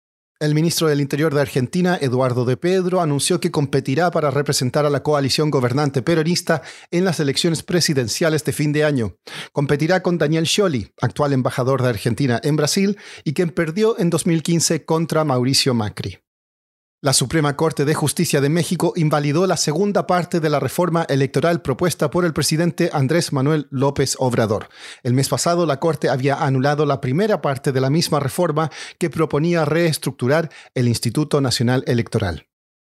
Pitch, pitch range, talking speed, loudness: 150 Hz, 135-170 Hz, 160 wpm, -19 LUFS